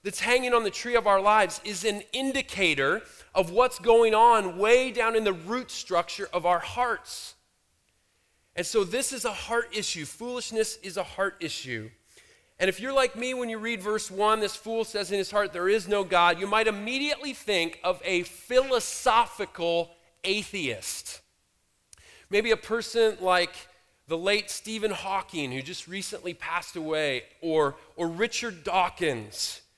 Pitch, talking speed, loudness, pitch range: 205 Hz, 165 wpm, -27 LUFS, 180-230 Hz